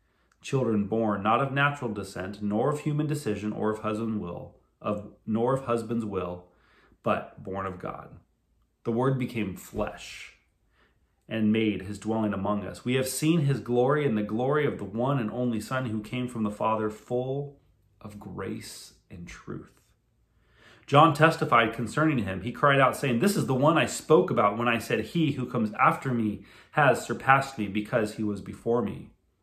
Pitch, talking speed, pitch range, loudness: 115 Hz, 180 wpm, 105-130 Hz, -27 LUFS